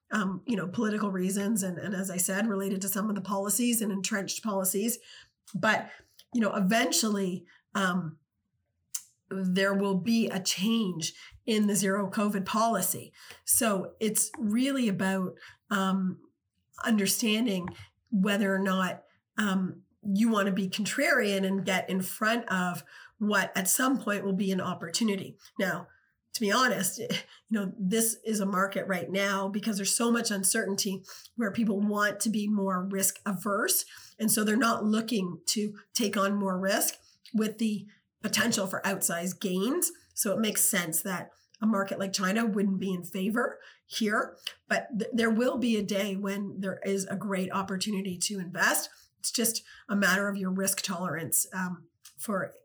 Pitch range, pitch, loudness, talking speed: 190-215 Hz, 200 Hz, -29 LUFS, 160 wpm